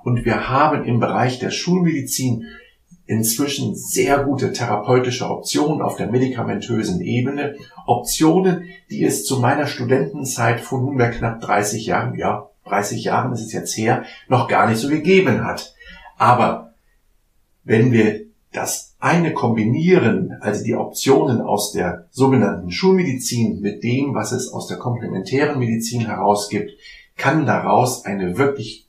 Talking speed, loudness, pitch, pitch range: 135 wpm, -19 LUFS, 125 Hz, 115-140 Hz